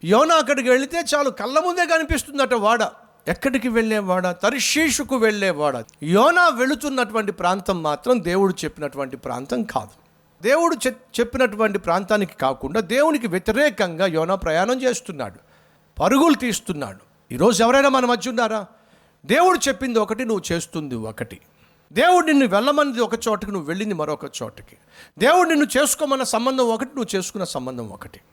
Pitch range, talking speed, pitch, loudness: 185-270 Hz, 130 wpm, 225 Hz, -20 LUFS